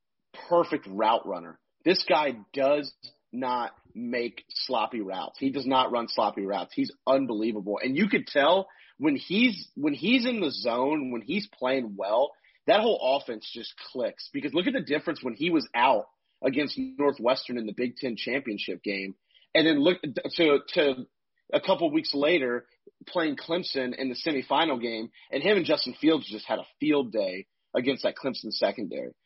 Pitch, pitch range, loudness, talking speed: 135 Hz, 120-175 Hz, -27 LUFS, 175 wpm